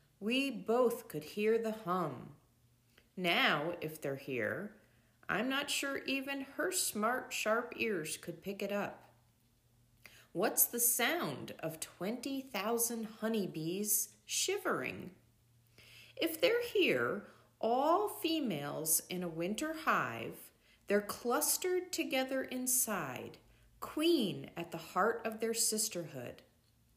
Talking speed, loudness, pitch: 110 wpm, -35 LUFS, 210 Hz